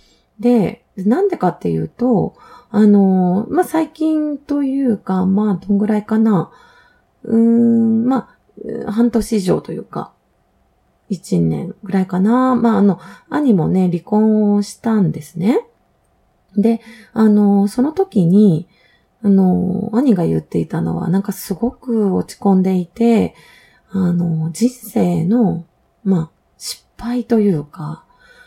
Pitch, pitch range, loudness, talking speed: 210 Hz, 185-235 Hz, -16 LUFS, 230 characters per minute